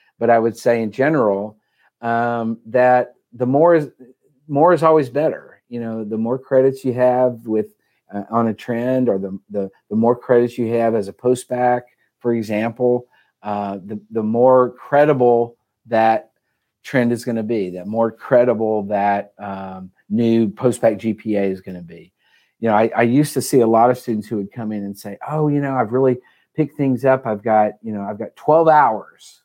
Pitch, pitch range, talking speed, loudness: 115 Hz, 110-125 Hz, 200 wpm, -18 LUFS